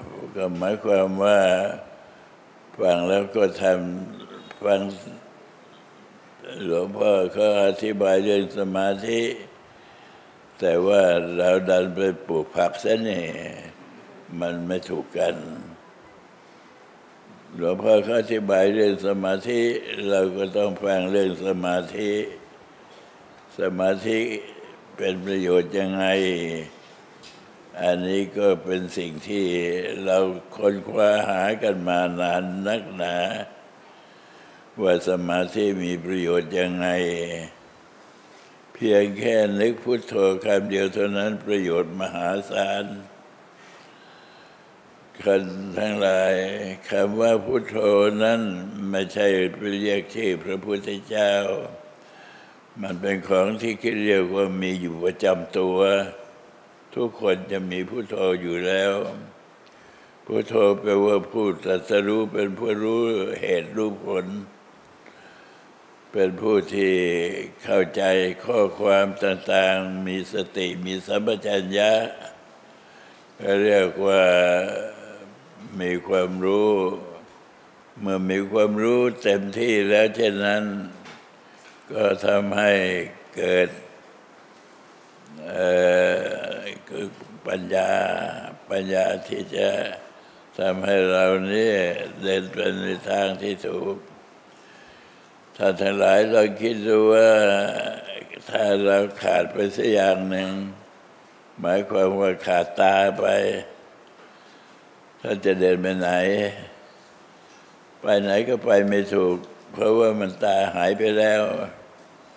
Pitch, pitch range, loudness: 95 Hz, 95-100 Hz, -22 LUFS